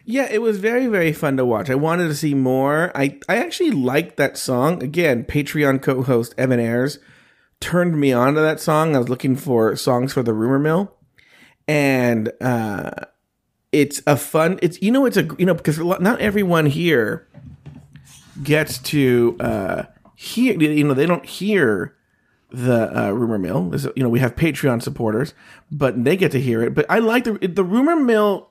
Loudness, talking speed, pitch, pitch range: -19 LUFS, 190 wpm, 145 Hz, 130-175 Hz